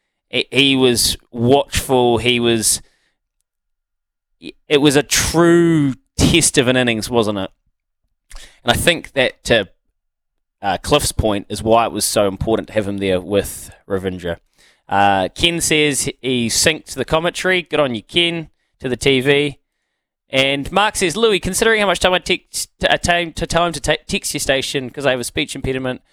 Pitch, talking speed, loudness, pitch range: 135 Hz, 170 wpm, -16 LUFS, 115-165 Hz